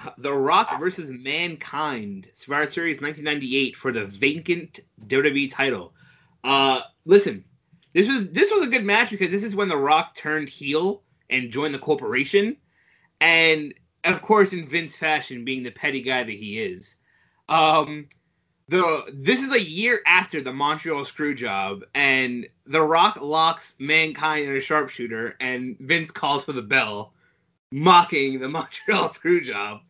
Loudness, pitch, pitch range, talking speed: -22 LUFS, 155 Hz, 135-180 Hz, 150 wpm